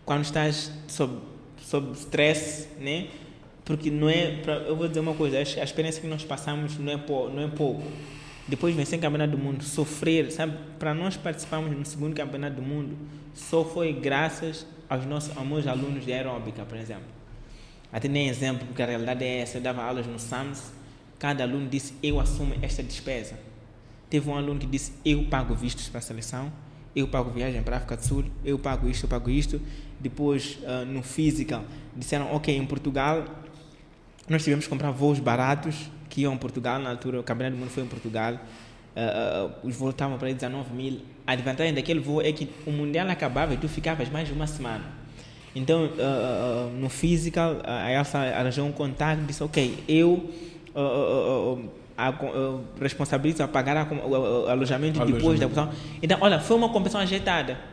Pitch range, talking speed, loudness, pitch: 130-155 Hz, 185 wpm, -28 LUFS, 145 Hz